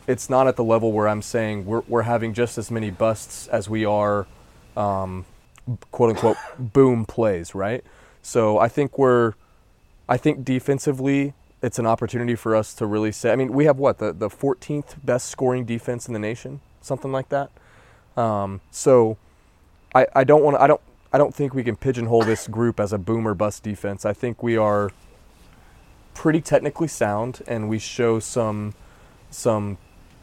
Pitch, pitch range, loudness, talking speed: 115 Hz, 105-130 Hz, -22 LUFS, 175 wpm